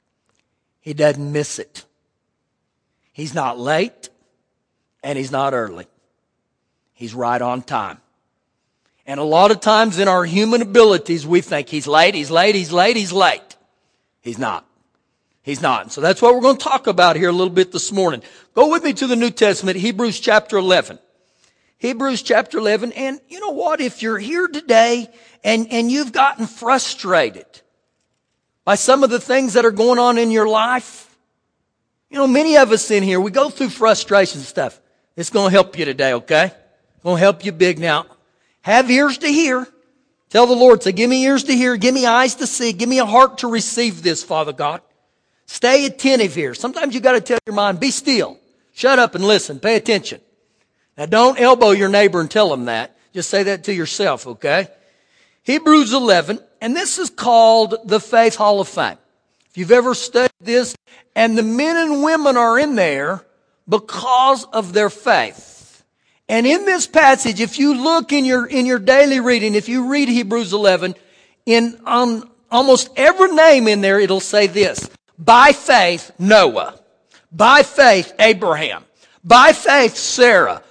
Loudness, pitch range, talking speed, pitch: -15 LUFS, 190-255 Hz, 180 wpm, 225 Hz